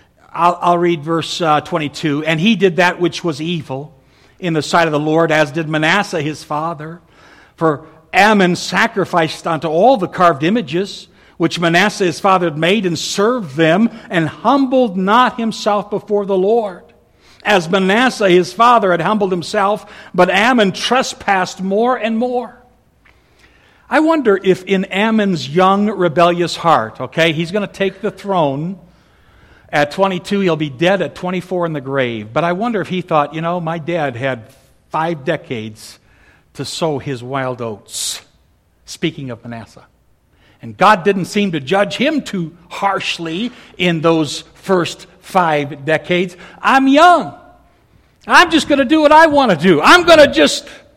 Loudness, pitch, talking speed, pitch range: -14 LUFS, 175 Hz, 160 wpm, 155-205 Hz